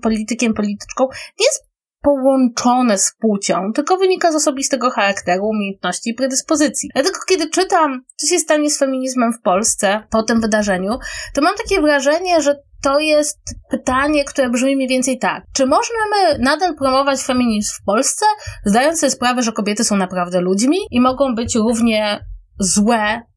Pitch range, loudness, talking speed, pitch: 220-295 Hz, -16 LUFS, 160 wpm, 260 Hz